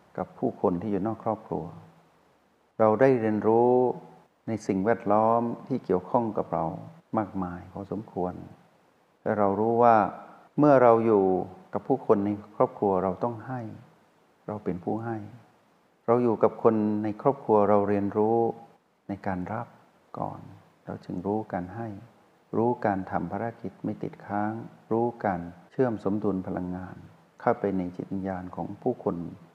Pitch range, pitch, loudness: 95-115 Hz, 105 Hz, -27 LUFS